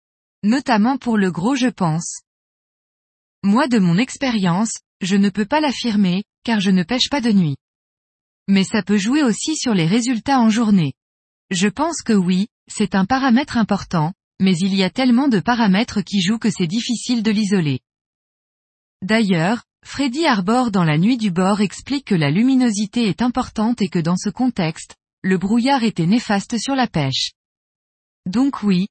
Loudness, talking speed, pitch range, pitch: -18 LUFS, 170 wpm, 190-245 Hz, 210 Hz